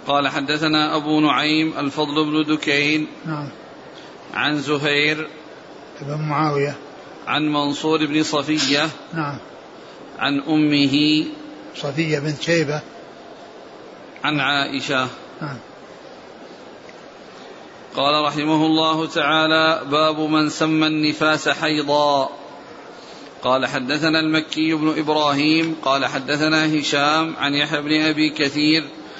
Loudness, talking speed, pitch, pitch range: -19 LUFS, 90 wpm, 150 Hz, 145-155 Hz